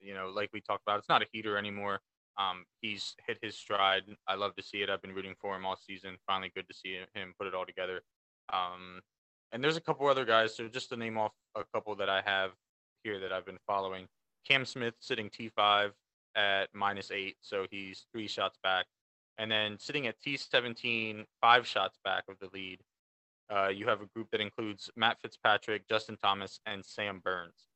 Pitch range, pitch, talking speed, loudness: 95-110 Hz, 100 Hz, 210 wpm, -34 LUFS